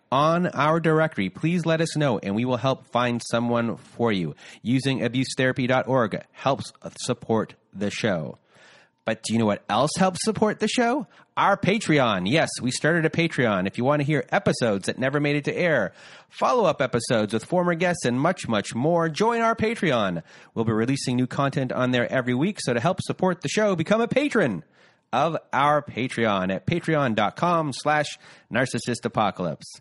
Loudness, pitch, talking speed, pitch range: -24 LUFS, 140 Hz, 175 wpm, 120-170 Hz